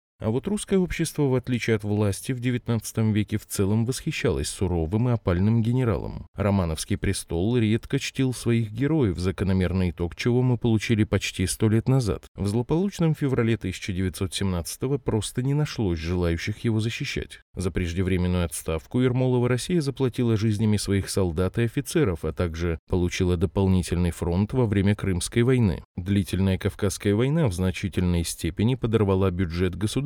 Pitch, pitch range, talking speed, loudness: 105 Hz, 95-125 Hz, 145 wpm, -25 LUFS